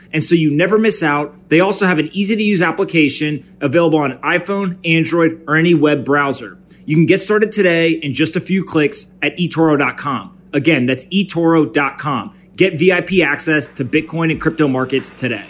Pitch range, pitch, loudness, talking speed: 150-185 Hz, 165 Hz, -14 LUFS, 180 wpm